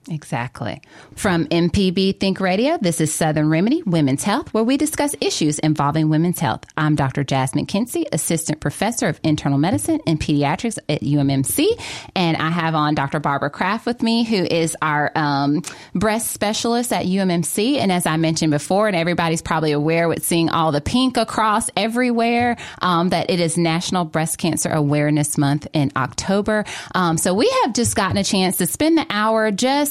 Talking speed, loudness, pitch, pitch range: 175 wpm, -19 LUFS, 170 Hz, 155-215 Hz